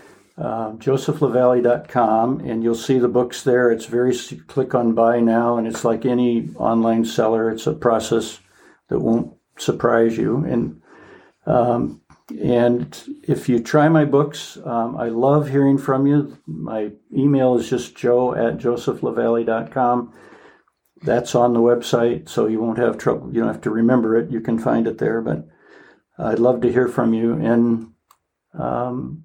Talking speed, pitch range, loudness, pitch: 160 wpm, 115-125 Hz, -19 LUFS, 120 Hz